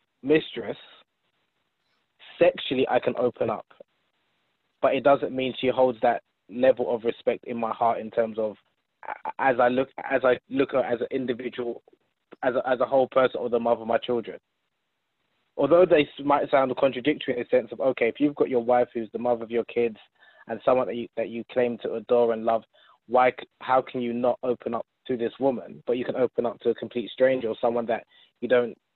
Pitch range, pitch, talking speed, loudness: 115-130 Hz, 125 Hz, 205 wpm, -25 LUFS